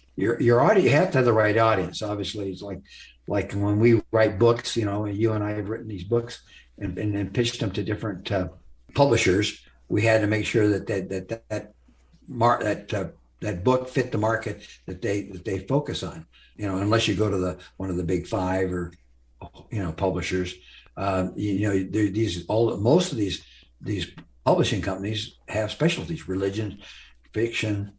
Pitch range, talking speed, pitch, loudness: 95-110 Hz, 195 wpm, 105 Hz, -25 LUFS